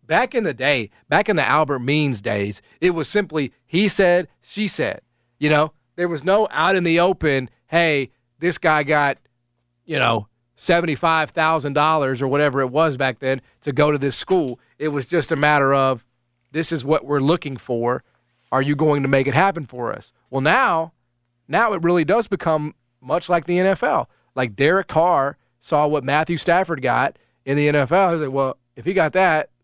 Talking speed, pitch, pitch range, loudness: 190 wpm, 150 Hz, 130-170 Hz, -19 LUFS